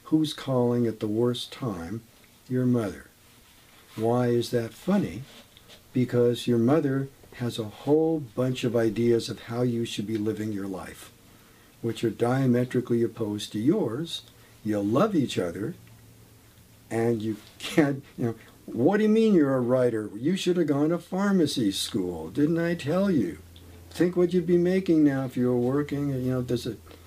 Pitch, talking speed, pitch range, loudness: 120 Hz, 170 wpm, 110-140 Hz, -26 LUFS